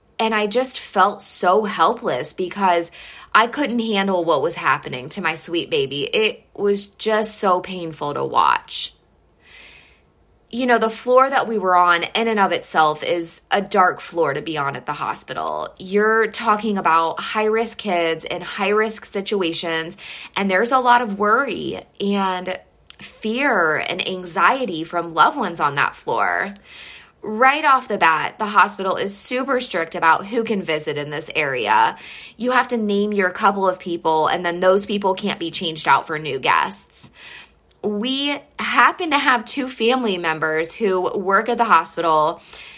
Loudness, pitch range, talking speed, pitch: -19 LUFS, 175-235 Hz, 165 wpm, 200 Hz